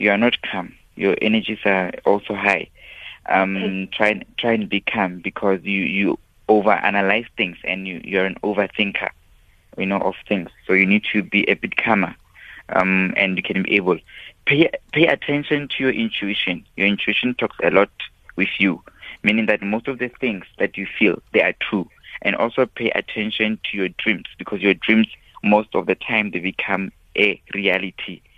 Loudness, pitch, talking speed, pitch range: -20 LUFS, 105 Hz, 185 wpm, 95-110 Hz